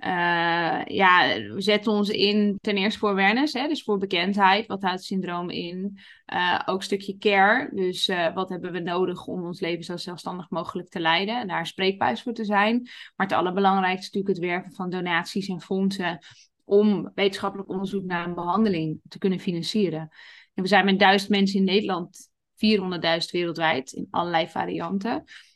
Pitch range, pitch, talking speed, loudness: 175-200 Hz, 190 Hz, 180 wpm, -24 LUFS